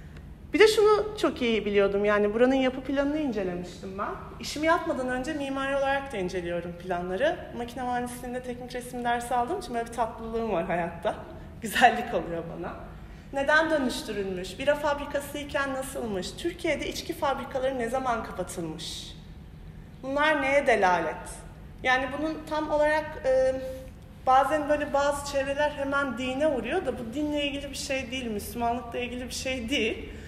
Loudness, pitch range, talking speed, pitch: -27 LUFS, 230-290 Hz, 145 wpm, 260 Hz